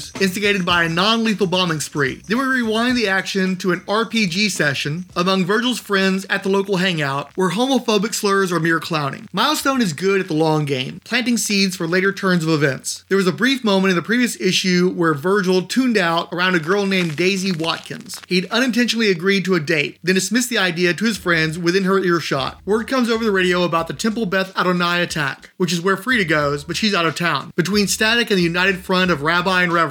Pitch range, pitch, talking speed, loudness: 170-210 Hz, 190 Hz, 220 wpm, -18 LUFS